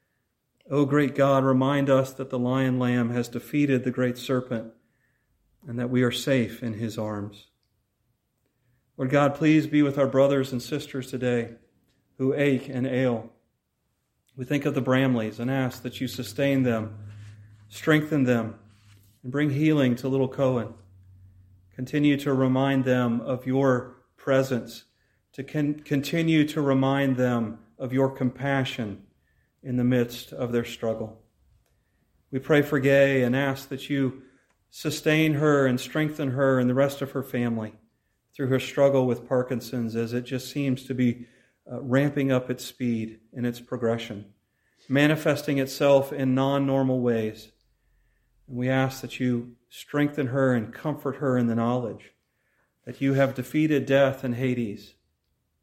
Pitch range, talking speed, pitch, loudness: 120-135 Hz, 150 wpm, 130 Hz, -25 LUFS